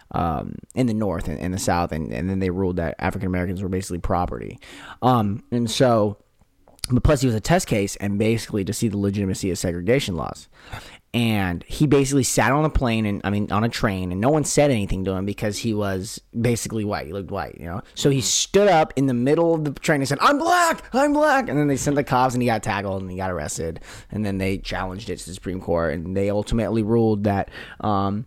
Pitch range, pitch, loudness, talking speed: 95-125 Hz, 105 Hz, -22 LUFS, 240 wpm